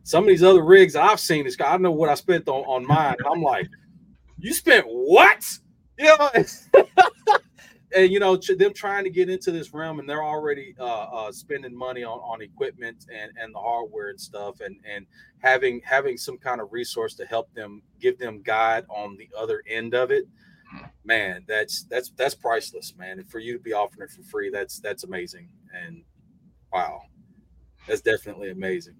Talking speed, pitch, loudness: 190 wpm, 185 Hz, -21 LUFS